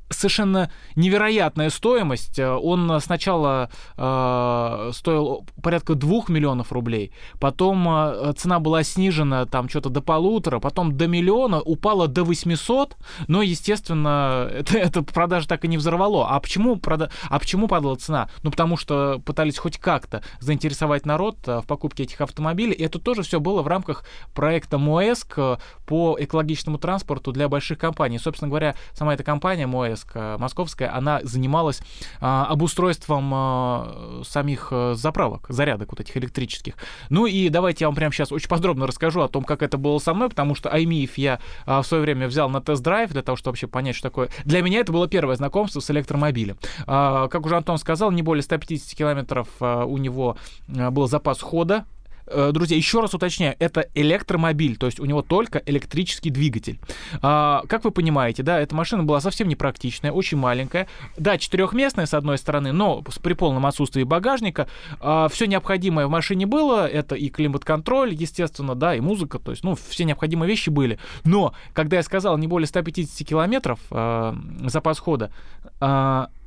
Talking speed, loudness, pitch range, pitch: 165 wpm, -22 LUFS, 135-175 Hz, 155 Hz